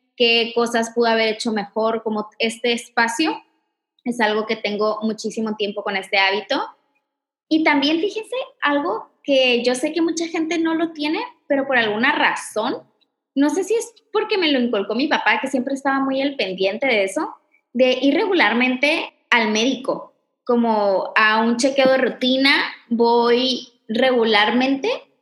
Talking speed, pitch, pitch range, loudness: 155 wpm, 255 Hz, 225-295 Hz, -19 LUFS